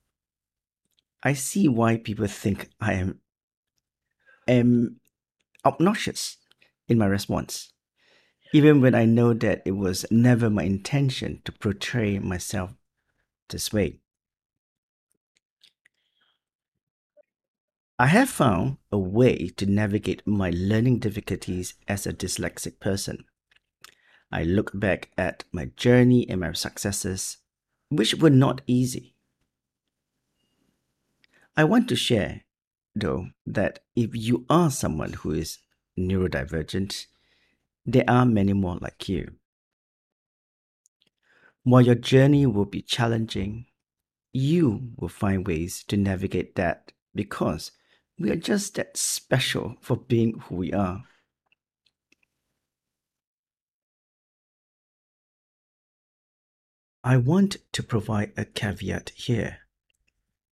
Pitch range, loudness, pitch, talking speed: 90-120 Hz, -24 LUFS, 100 Hz, 105 wpm